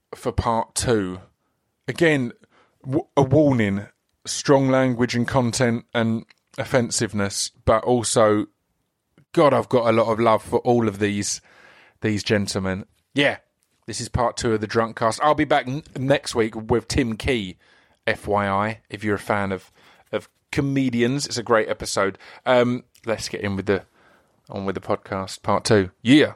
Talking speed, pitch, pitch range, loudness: 160 wpm, 115 Hz, 100-125 Hz, -22 LUFS